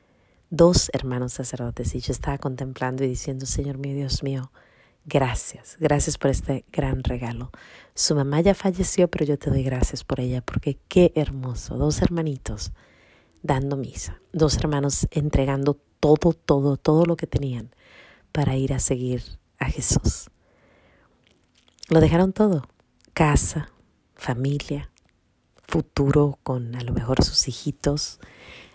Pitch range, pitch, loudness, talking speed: 125-150 Hz, 135 Hz, -23 LUFS, 135 wpm